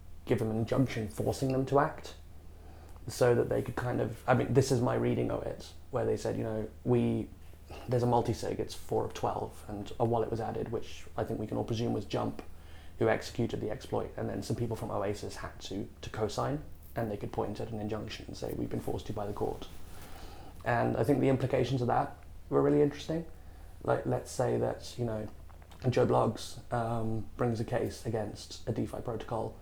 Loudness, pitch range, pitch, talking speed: -33 LUFS, 85-115 Hz, 105 Hz, 215 wpm